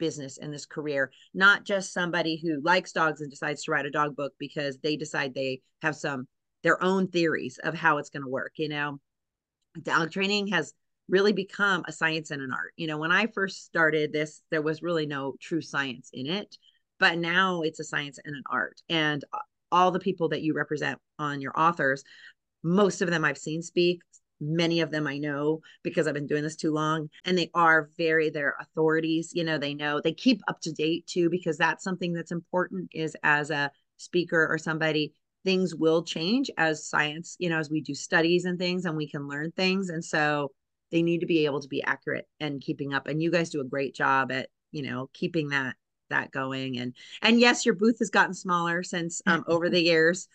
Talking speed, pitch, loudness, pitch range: 215 wpm, 160 Hz, -27 LUFS, 150-175 Hz